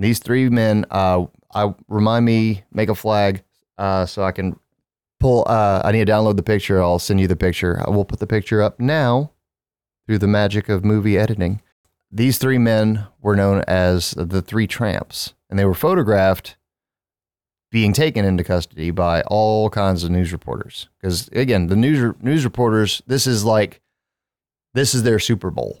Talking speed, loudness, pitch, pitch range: 180 wpm, -18 LUFS, 105 Hz, 95-110 Hz